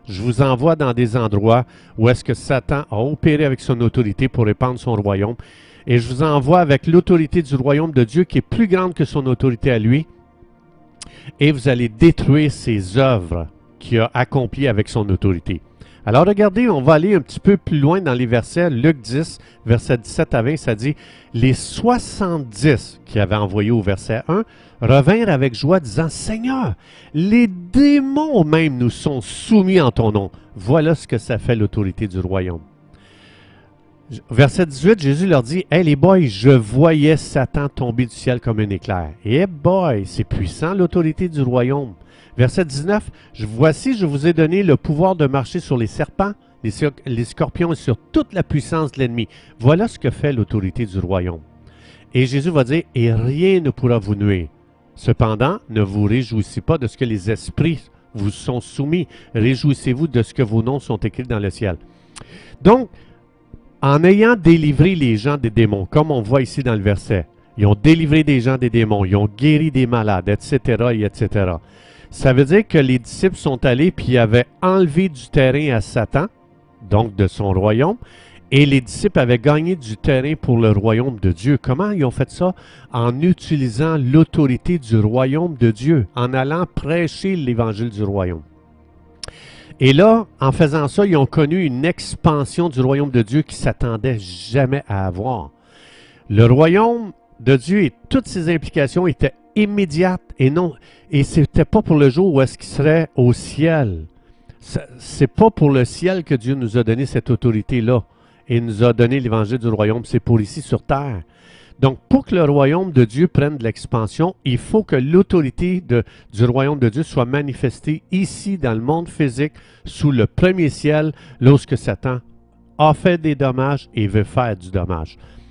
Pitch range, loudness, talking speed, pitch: 115-160 Hz, -17 LUFS, 180 wpm, 130 Hz